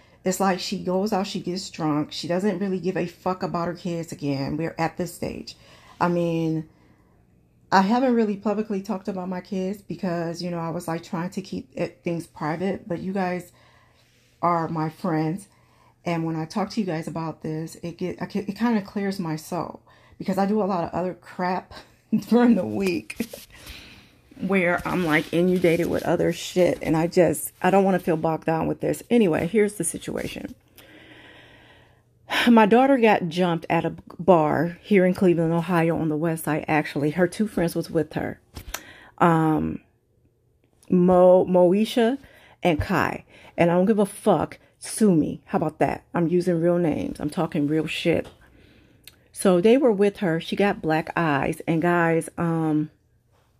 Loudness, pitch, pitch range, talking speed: -23 LUFS, 175 Hz, 160-190 Hz, 180 wpm